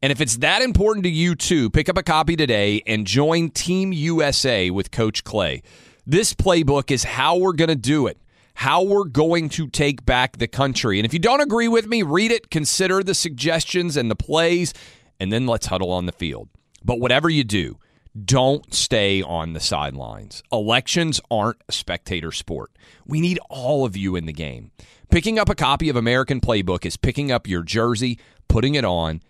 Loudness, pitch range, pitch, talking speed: -20 LUFS, 105-165 Hz, 135 Hz, 195 wpm